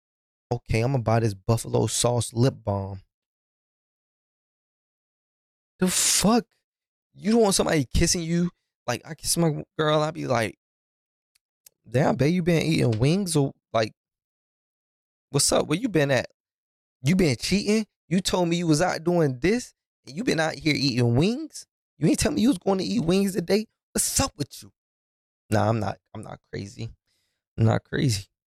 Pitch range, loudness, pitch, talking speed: 110-180 Hz, -24 LUFS, 140 Hz, 170 wpm